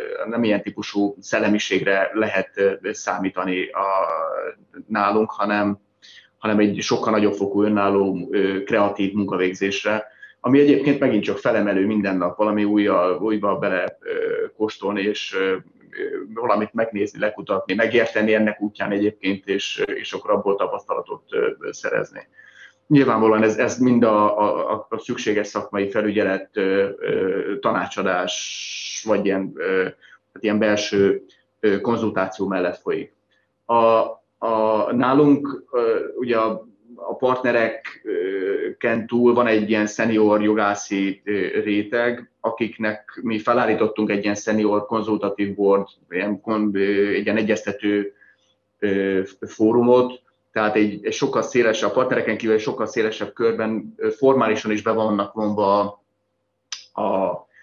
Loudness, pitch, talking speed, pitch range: -21 LUFS, 105 Hz, 115 wpm, 100-120 Hz